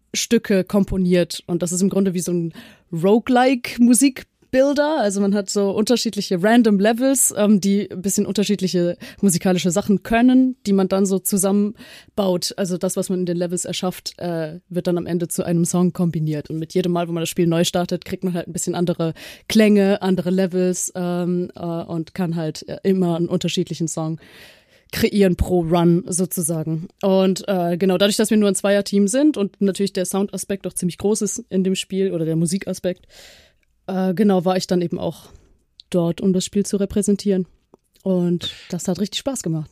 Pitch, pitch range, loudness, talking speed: 190 Hz, 175-200 Hz, -20 LUFS, 190 wpm